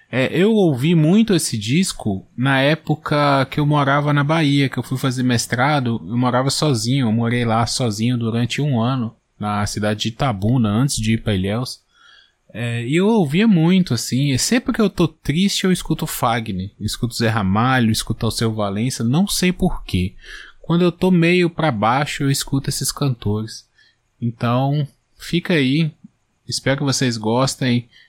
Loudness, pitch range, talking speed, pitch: -18 LUFS, 115-155 Hz, 165 wpm, 130 Hz